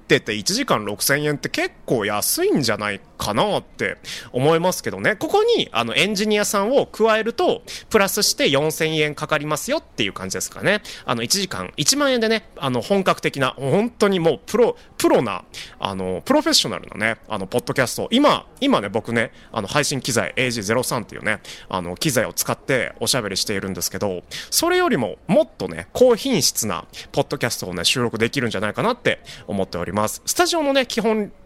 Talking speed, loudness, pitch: 395 characters per minute, -20 LUFS, 175 Hz